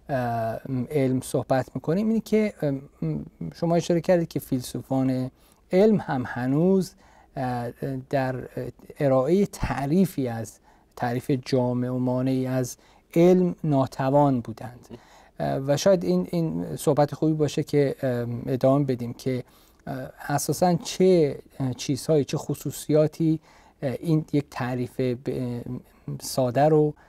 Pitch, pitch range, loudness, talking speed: 135 Hz, 125-155 Hz, -25 LUFS, 100 wpm